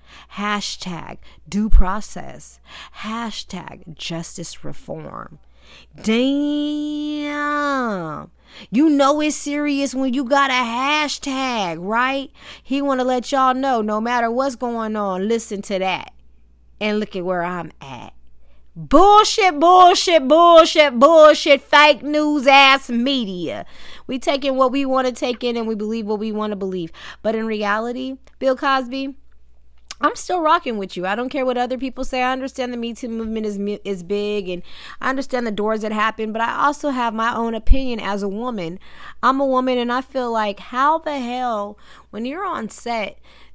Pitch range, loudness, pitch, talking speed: 210-275 Hz, -18 LUFS, 245 Hz, 165 wpm